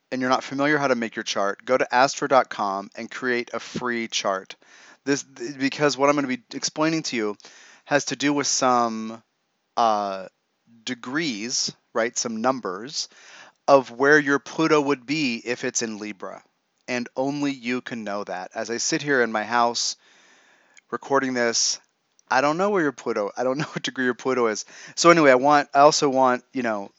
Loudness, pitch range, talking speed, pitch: -23 LUFS, 115-145 Hz, 190 wpm, 130 Hz